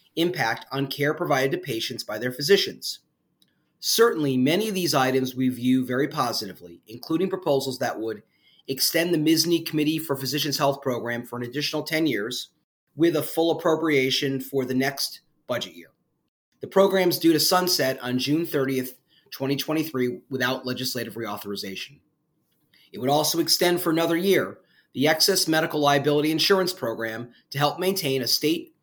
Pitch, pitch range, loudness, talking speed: 145 Hz, 130-165 Hz, -24 LUFS, 155 wpm